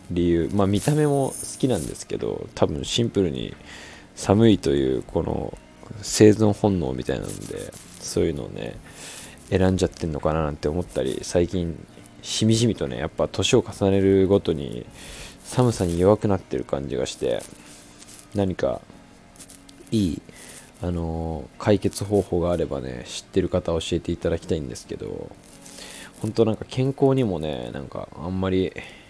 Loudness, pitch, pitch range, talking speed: -24 LUFS, 95 Hz, 85-105 Hz, 305 characters per minute